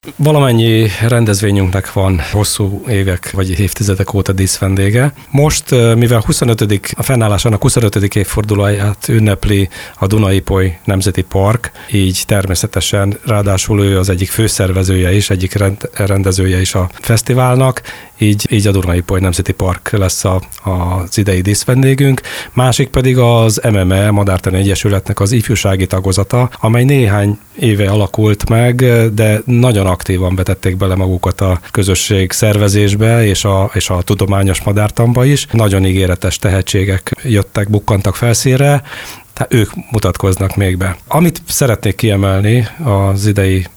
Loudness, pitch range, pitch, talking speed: -12 LUFS, 95-115 Hz, 100 Hz, 125 wpm